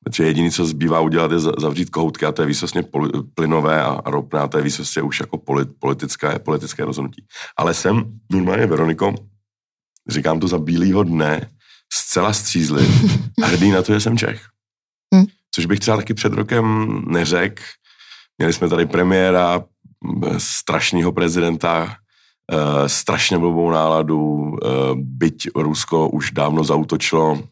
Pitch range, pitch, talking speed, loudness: 80-105 Hz, 85 Hz, 130 wpm, -18 LUFS